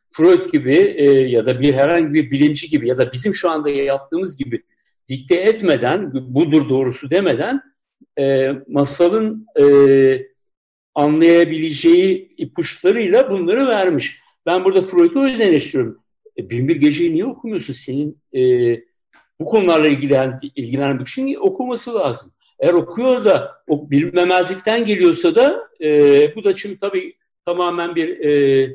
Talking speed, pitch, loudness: 130 wpm, 180 Hz, -16 LUFS